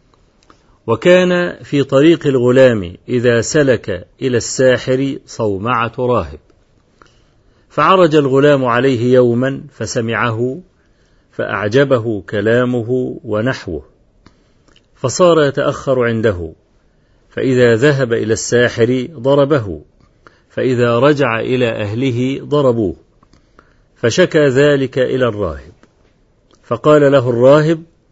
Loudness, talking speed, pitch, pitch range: -14 LUFS, 80 wpm, 130 Hz, 115-140 Hz